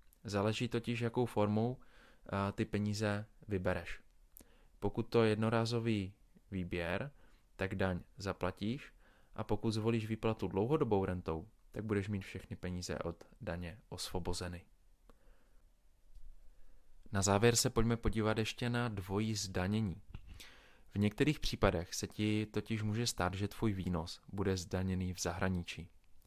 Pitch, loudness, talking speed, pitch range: 100 Hz, -37 LUFS, 120 wpm, 90-110 Hz